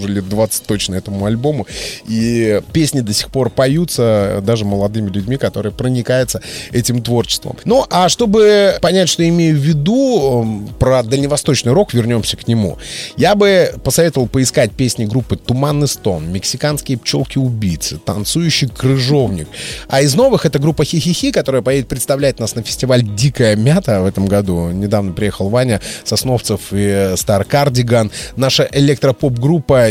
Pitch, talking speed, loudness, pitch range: 125 Hz, 140 wpm, -14 LUFS, 105-145 Hz